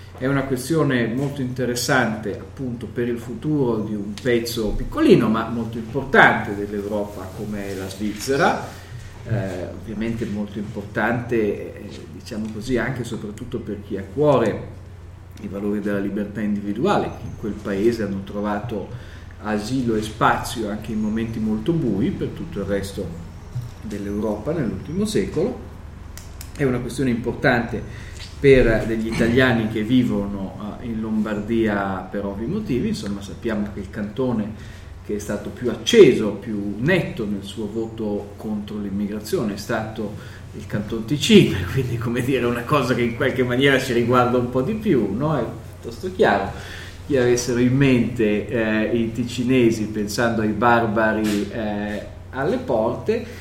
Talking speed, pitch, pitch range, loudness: 145 wpm, 110 Hz, 100-120 Hz, -22 LUFS